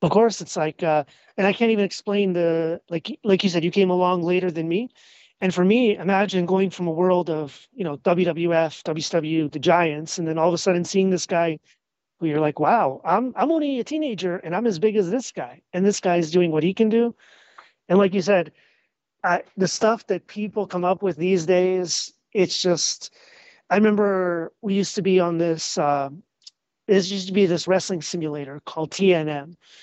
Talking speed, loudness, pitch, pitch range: 210 wpm, -22 LUFS, 180 Hz, 165-200 Hz